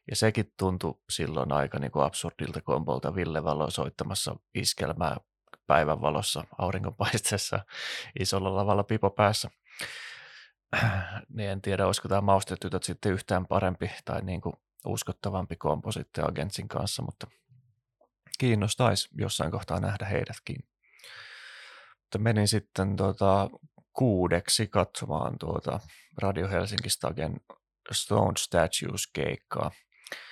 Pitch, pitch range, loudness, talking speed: 95 Hz, 90-110 Hz, -29 LUFS, 105 wpm